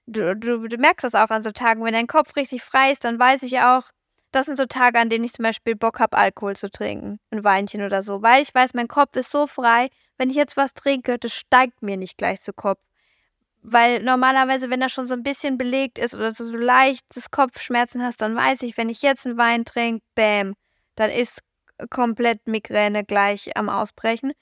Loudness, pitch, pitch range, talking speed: -20 LUFS, 240 Hz, 225-260 Hz, 220 wpm